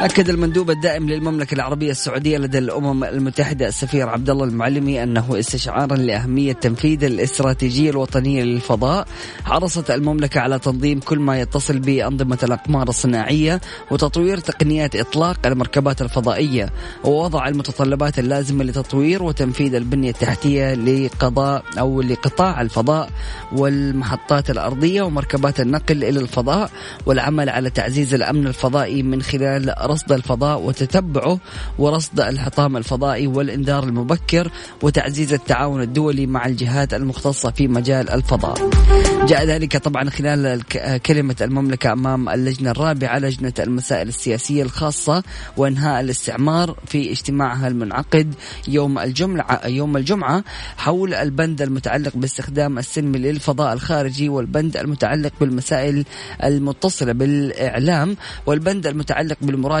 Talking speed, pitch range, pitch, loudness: 110 wpm, 130-150 Hz, 140 Hz, -19 LUFS